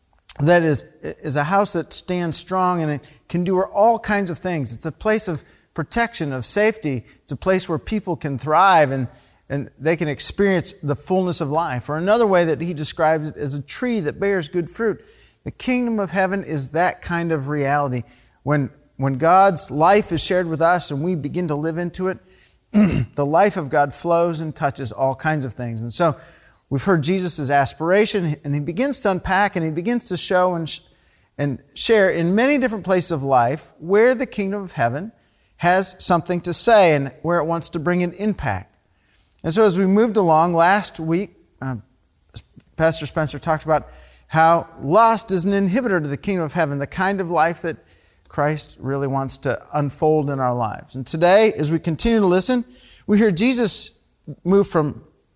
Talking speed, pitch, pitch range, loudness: 195 wpm, 165 Hz, 145-190 Hz, -19 LUFS